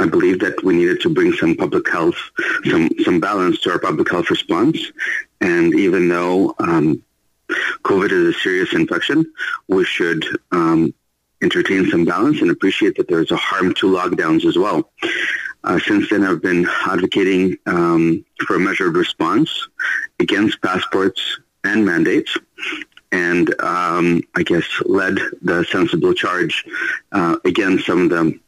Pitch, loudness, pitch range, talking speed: 340 Hz, -17 LUFS, 320-360 Hz, 150 wpm